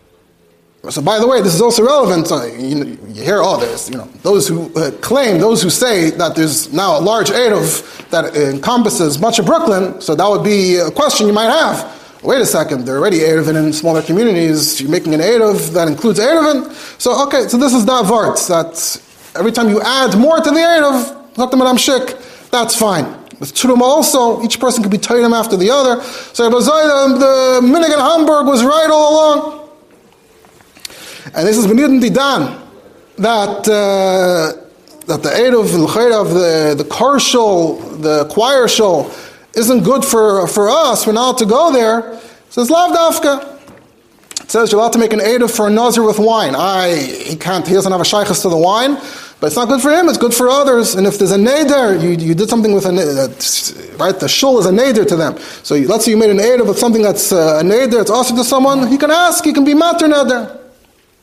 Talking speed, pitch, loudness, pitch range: 210 wpm, 230 Hz, -12 LUFS, 190-270 Hz